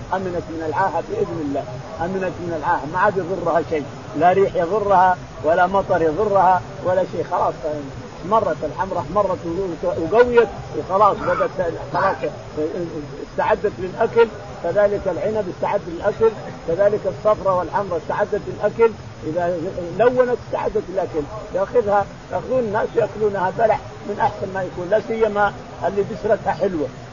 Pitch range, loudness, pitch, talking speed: 165-210 Hz, -20 LUFS, 185 Hz, 125 wpm